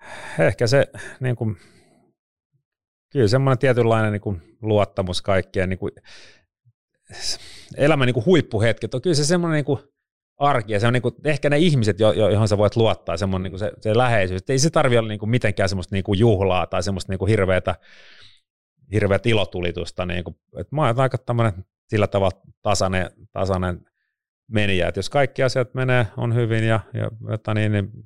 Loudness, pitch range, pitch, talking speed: -21 LUFS, 95-125 Hz, 110 Hz, 160 wpm